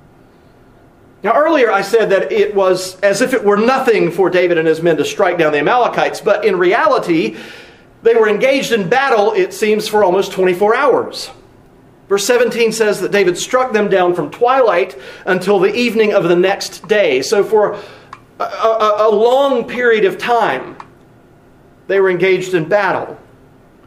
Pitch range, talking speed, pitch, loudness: 190-255 Hz, 170 wpm, 215 Hz, -13 LUFS